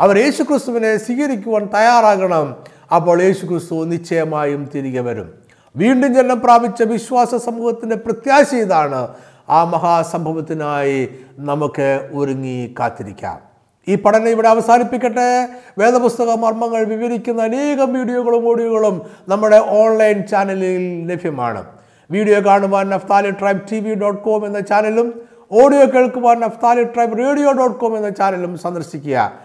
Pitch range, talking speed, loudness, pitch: 165-235 Hz, 115 wpm, -15 LUFS, 210 Hz